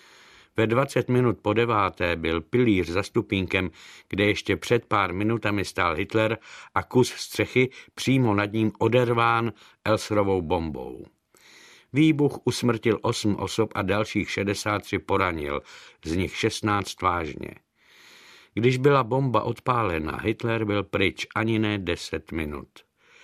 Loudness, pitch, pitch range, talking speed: -25 LUFS, 105 Hz, 100-120 Hz, 125 wpm